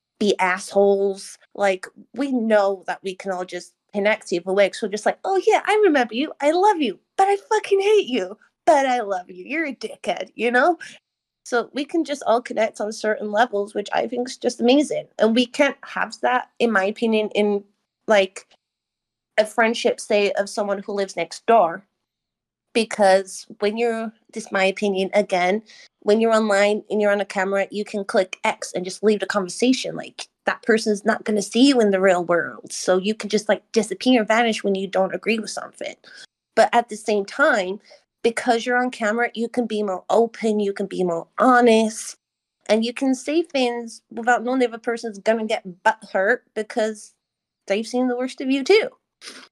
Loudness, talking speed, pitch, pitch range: -21 LUFS, 200 wpm, 215 Hz, 200-245 Hz